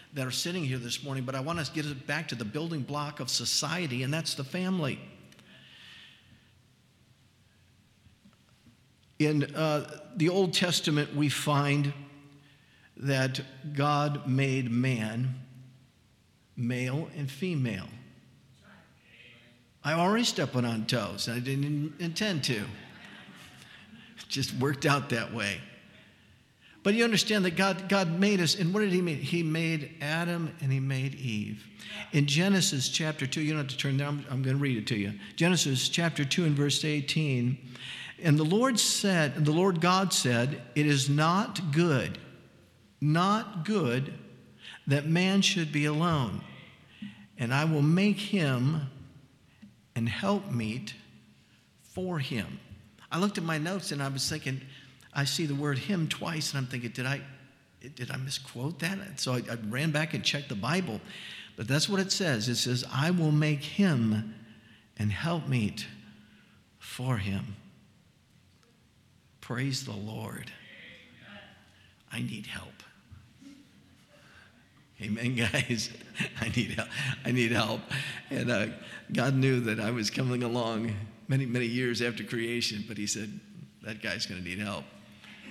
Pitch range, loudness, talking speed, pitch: 120-155 Hz, -29 LUFS, 150 wpm, 135 Hz